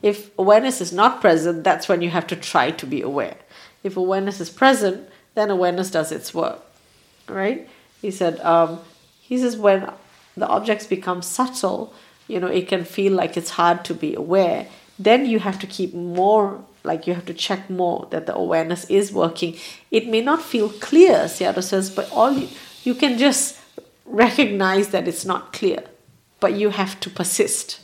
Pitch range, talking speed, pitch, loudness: 175-215 Hz, 185 wpm, 195 Hz, -20 LUFS